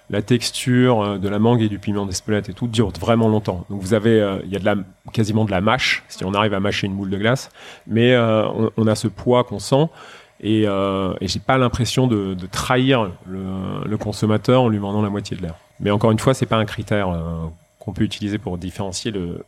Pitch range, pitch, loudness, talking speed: 100-115 Hz, 105 Hz, -20 LUFS, 240 wpm